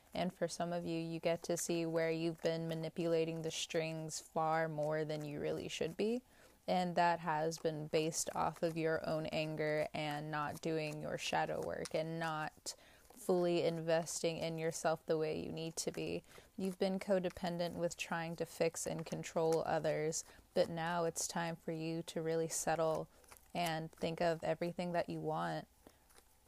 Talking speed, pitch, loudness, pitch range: 170 wpm, 165 Hz, -39 LUFS, 160-170 Hz